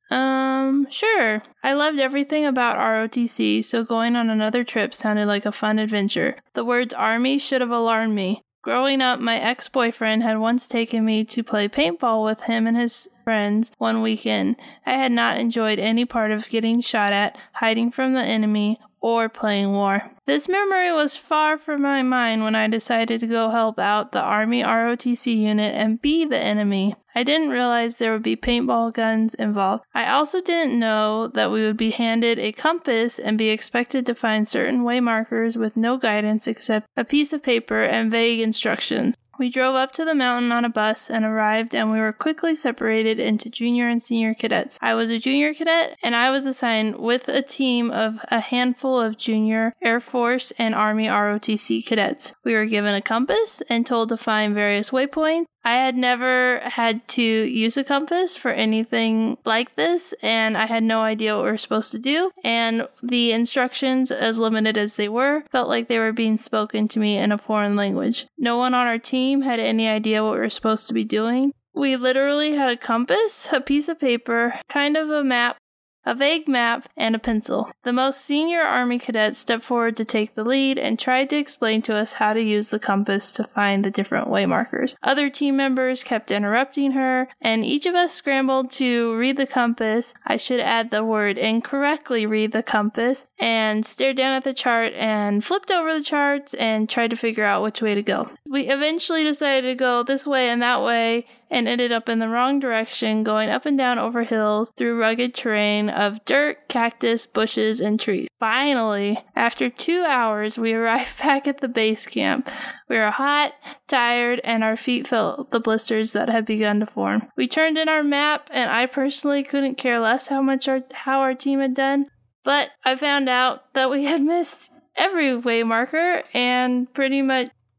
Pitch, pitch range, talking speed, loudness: 235 Hz, 220-265 Hz, 195 wpm, -21 LUFS